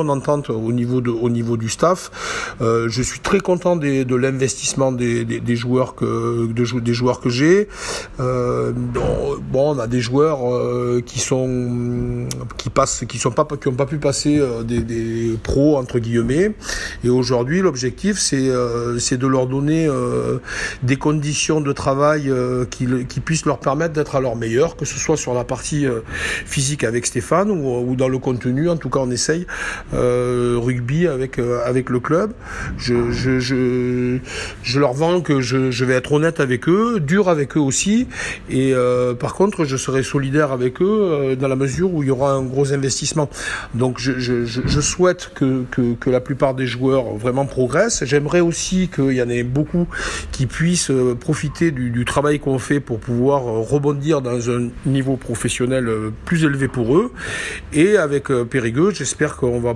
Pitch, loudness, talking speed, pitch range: 130 Hz, -19 LUFS, 180 wpm, 125-150 Hz